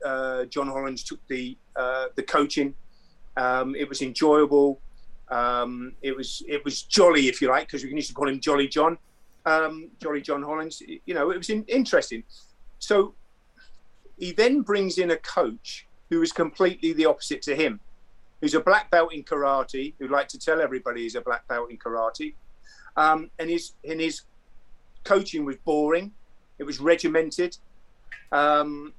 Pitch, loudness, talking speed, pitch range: 150 Hz, -25 LUFS, 170 wpm, 135-170 Hz